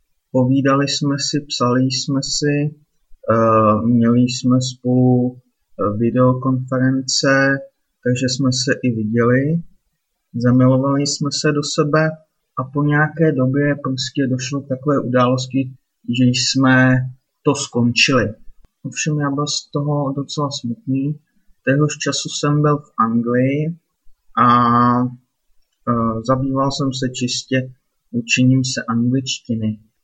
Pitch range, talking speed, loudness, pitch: 125-145 Hz, 105 wpm, -17 LUFS, 130 Hz